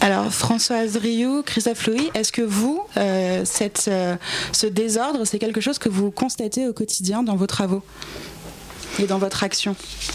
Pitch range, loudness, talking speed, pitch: 200-235 Hz, -21 LUFS, 165 wpm, 220 Hz